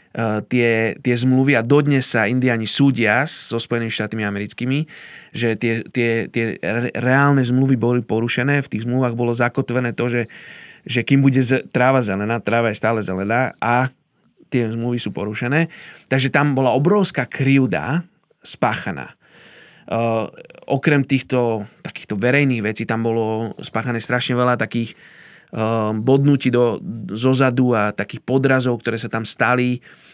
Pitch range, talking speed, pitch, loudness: 115-135 Hz, 140 wpm, 120 Hz, -19 LUFS